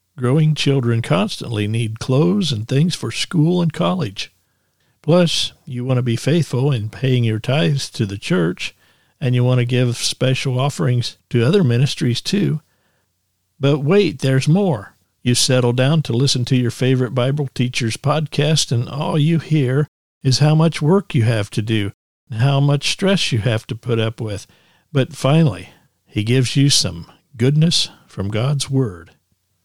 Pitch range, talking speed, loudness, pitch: 115-150 Hz, 165 wpm, -18 LUFS, 130 Hz